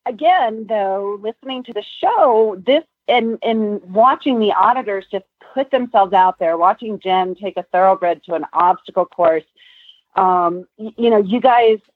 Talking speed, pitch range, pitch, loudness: 160 wpm, 185-240 Hz, 210 Hz, -16 LUFS